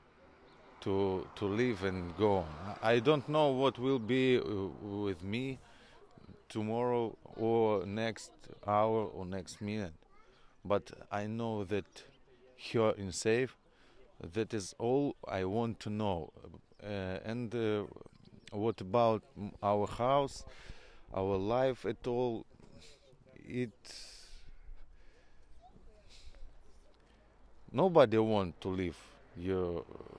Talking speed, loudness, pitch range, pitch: 105 wpm, -34 LUFS, 95-115 Hz, 105 Hz